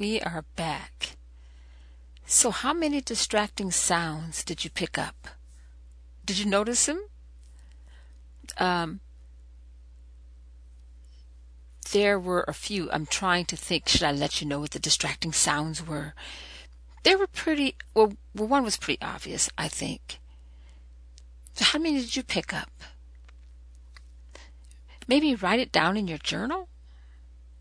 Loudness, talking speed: -26 LUFS, 130 wpm